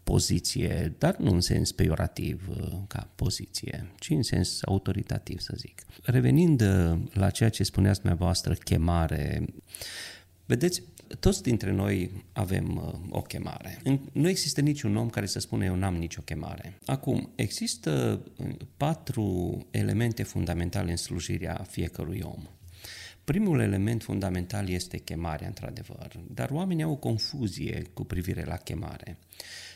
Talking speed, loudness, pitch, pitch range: 130 wpm, -29 LUFS, 100 Hz, 90-125 Hz